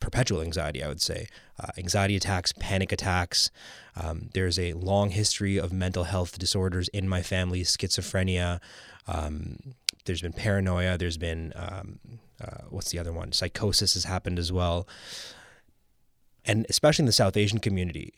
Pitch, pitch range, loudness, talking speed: 95 Hz, 90-100 Hz, -27 LUFS, 155 wpm